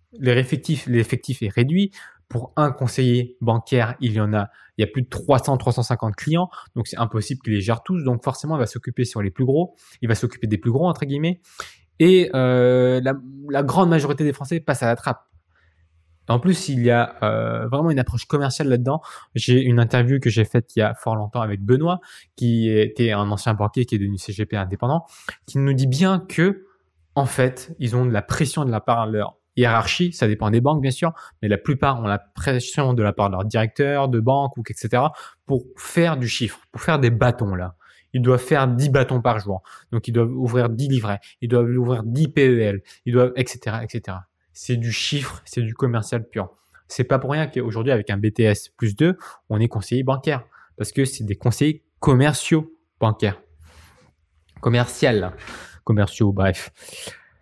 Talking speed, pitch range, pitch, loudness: 200 wpm, 110-135 Hz, 125 Hz, -21 LUFS